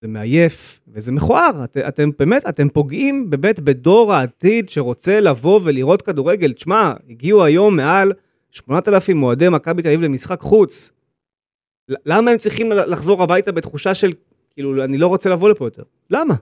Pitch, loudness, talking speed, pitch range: 170 Hz, -15 LUFS, 155 wpm, 140-200 Hz